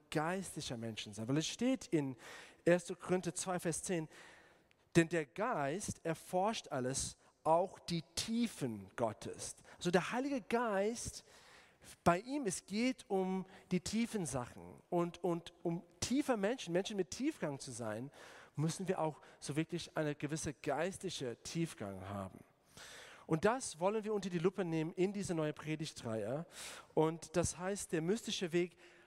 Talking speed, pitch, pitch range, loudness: 145 wpm, 175 Hz, 155-190 Hz, -39 LUFS